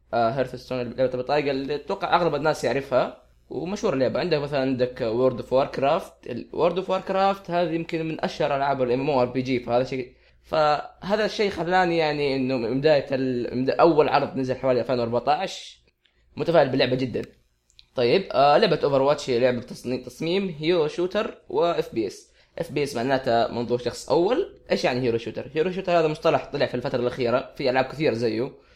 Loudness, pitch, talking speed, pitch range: -24 LUFS, 140 Hz, 185 wpm, 125-170 Hz